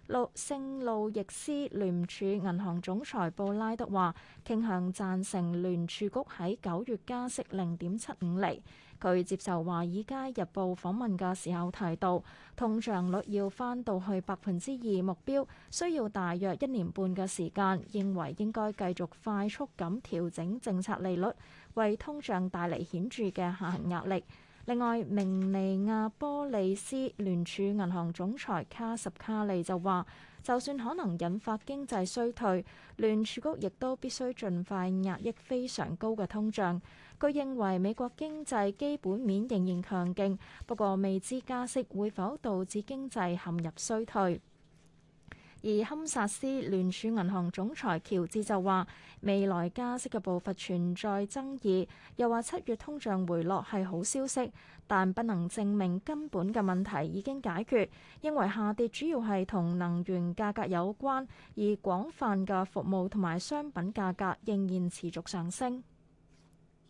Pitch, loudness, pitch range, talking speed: 200 Hz, -34 LUFS, 185-230 Hz, 230 characters per minute